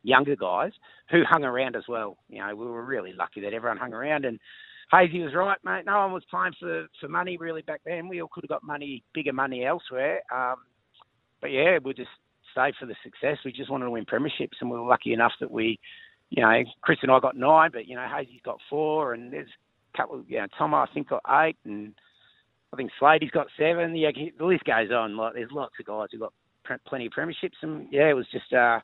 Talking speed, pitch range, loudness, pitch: 235 wpm, 120-160 Hz, -26 LUFS, 145 Hz